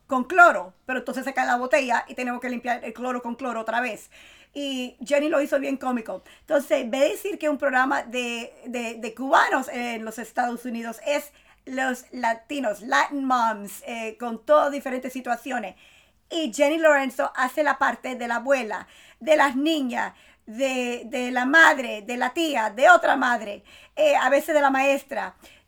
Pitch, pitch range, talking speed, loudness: 260 Hz, 240-290 Hz, 180 wpm, -23 LUFS